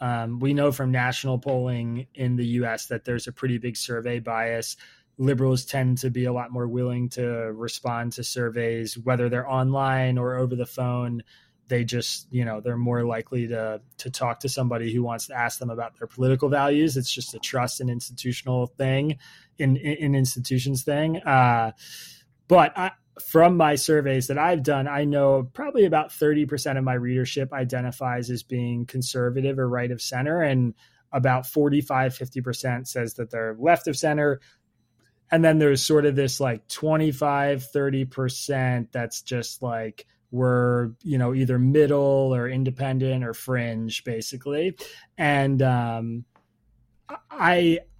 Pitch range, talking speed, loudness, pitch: 120-140 Hz, 160 wpm, -24 LUFS, 125 Hz